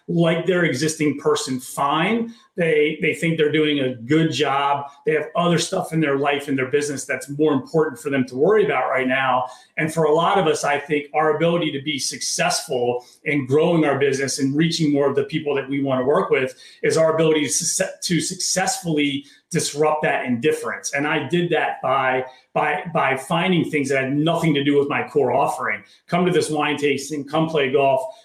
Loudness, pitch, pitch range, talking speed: -20 LUFS, 150 Hz, 140-160 Hz, 205 wpm